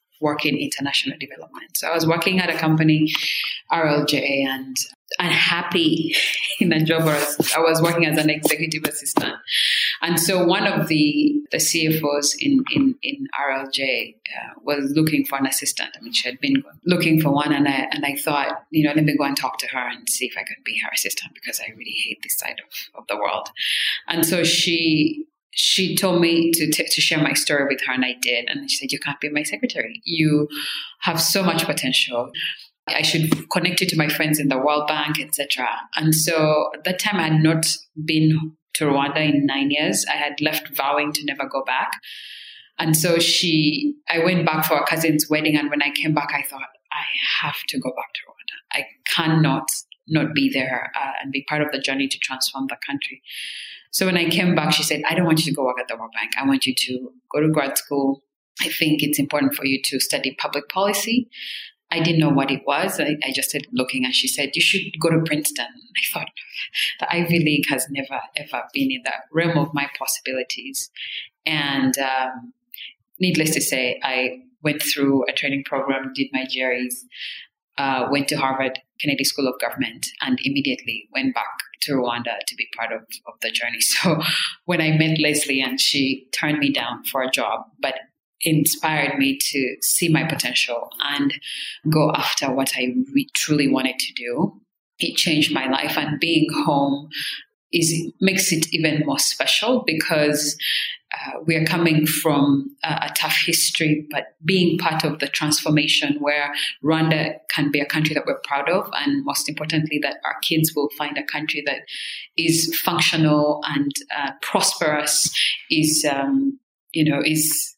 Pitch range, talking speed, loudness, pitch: 140-165 Hz, 195 wpm, -20 LUFS, 155 Hz